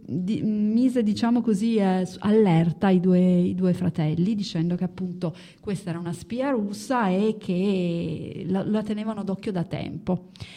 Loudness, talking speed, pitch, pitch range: -24 LUFS, 155 wpm, 185 Hz, 175-215 Hz